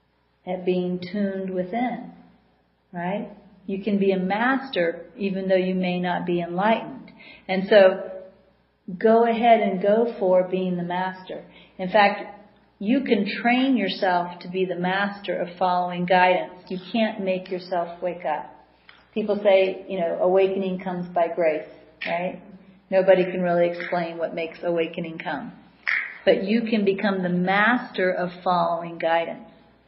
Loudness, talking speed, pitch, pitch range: -23 LUFS, 145 wpm, 185 Hz, 180-205 Hz